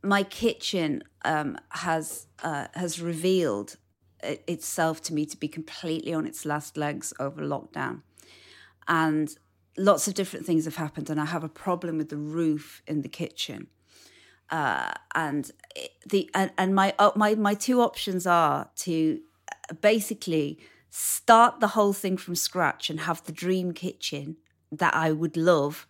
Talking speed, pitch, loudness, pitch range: 160 wpm, 170 Hz, -27 LUFS, 155-190 Hz